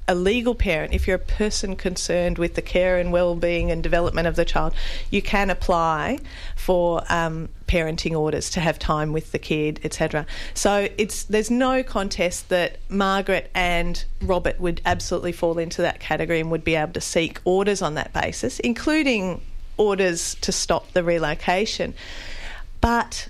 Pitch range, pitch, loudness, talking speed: 165-195 Hz, 175 Hz, -23 LUFS, 165 wpm